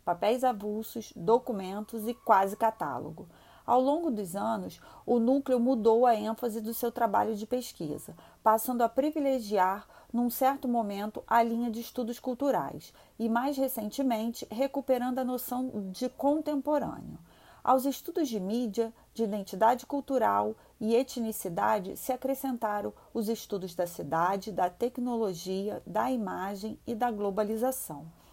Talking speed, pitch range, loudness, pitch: 130 wpm, 210-255 Hz, -30 LUFS, 230 Hz